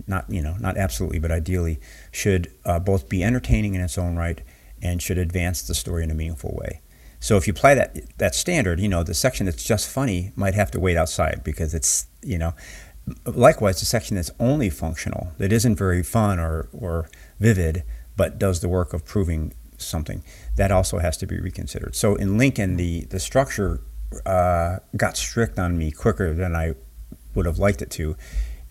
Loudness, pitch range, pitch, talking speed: -23 LUFS, 80-100 Hz, 90 Hz, 195 wpm